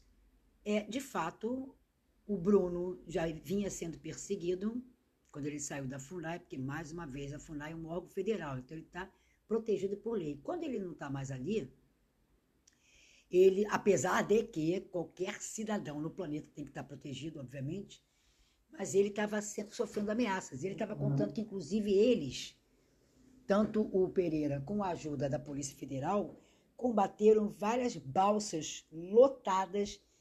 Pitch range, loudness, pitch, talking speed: 155-210 Hz, -35 LUFS, 190 Hz, 145 wpm